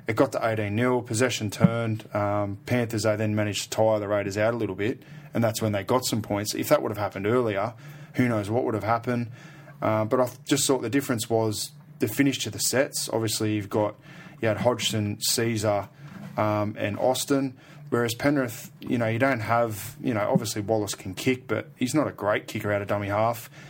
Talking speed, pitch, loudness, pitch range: 215 wpm, 115 Hz, -26 LUFS, 105-130 Hz